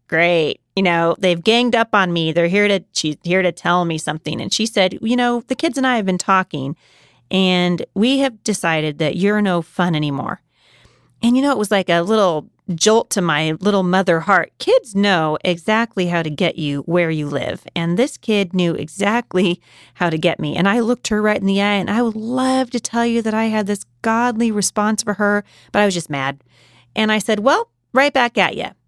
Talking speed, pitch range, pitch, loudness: 220 wpm, 170-220 Hz, 195 Hz, -17 LUFS